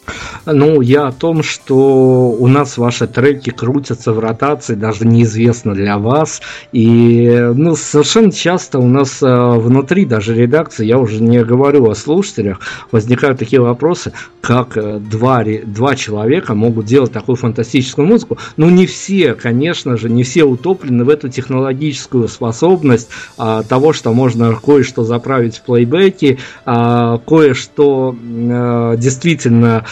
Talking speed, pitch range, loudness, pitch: 130 wpm, 115-145 Hz, -12 LUFS, 125 Hz